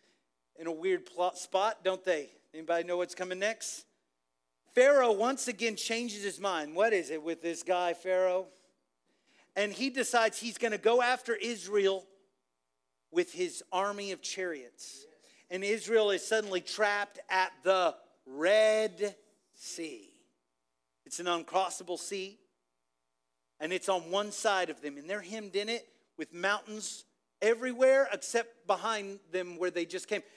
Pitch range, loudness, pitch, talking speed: 175-225 Hz, -32 LUFS, 195 Hz, 145 wpm